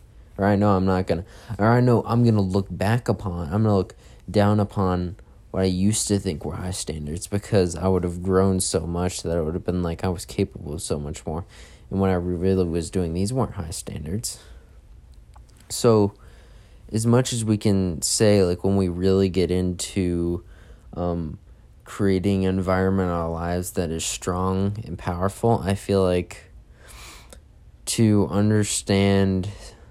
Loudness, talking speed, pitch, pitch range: -23 LUFS, 175 wpm, 95 Hz, 90-100 Hz